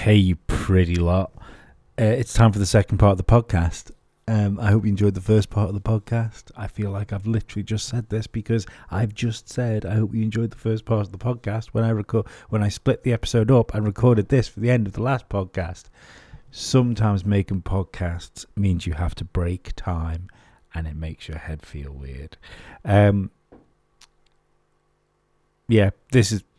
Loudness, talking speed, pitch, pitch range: -22 LUFS, 195 wpm, 105 Hz, 95-115 Hz